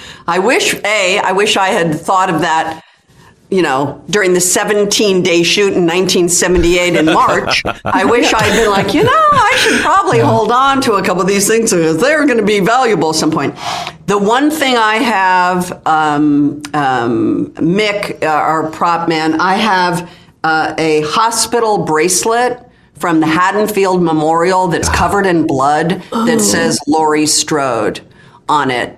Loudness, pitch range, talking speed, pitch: -12 LUFS, 160-210 Hz, 165 wpm, 180 Hz